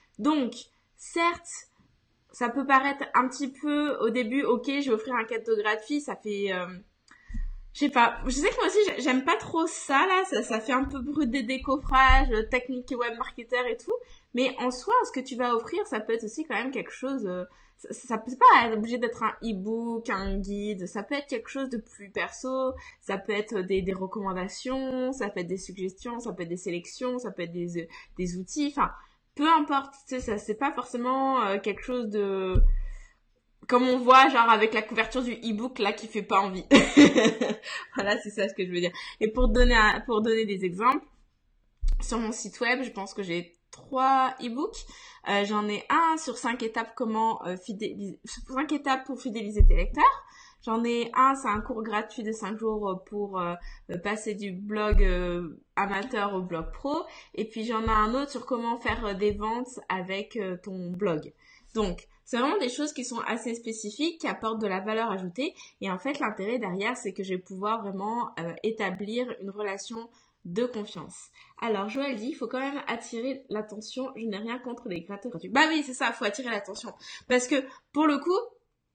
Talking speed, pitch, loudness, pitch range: 205 wpm, 230 Hz, -28 LUFS, 205-260 Hz